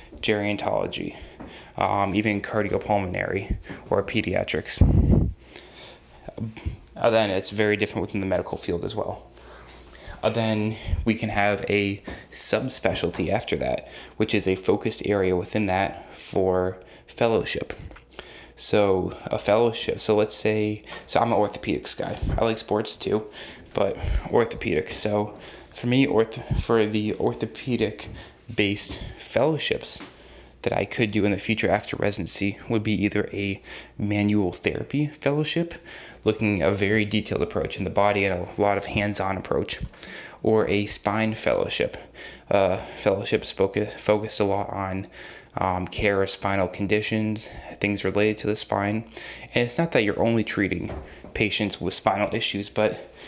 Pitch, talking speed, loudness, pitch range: 105 Hz, 140 wpm, -24 LUFS, 95-110 Hz